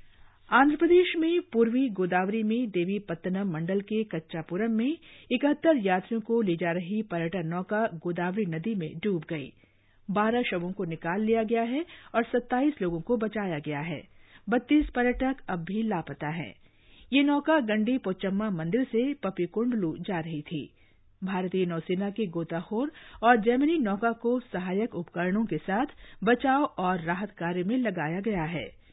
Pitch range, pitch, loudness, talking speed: 170-240 Hz, 200 Hz, -28 LUFS, 155 wpm